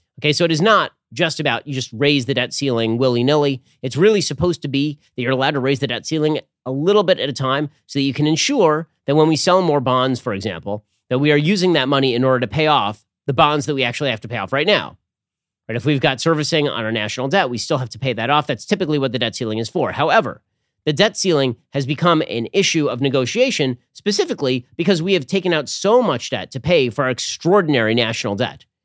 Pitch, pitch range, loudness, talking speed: 140 Hz, 125-160 Hz, -18 LUFS, 245 wpm